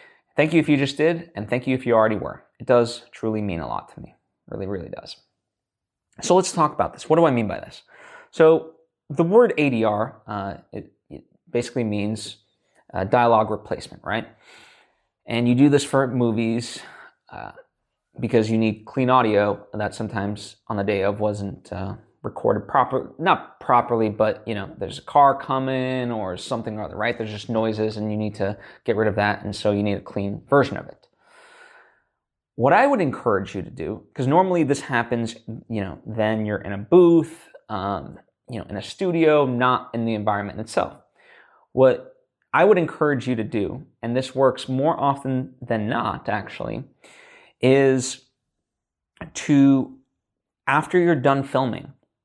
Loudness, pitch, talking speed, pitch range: -22 LUFS, 120 Hz, 180 wpm, 110-140 Hz